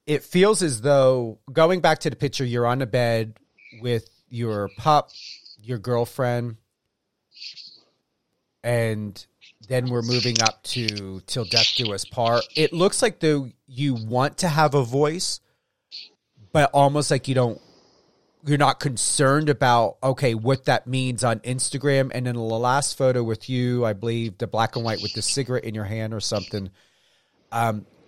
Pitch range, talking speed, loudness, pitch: 115-140 Hz, 165 wpm, -22 LUFS, 125 Hz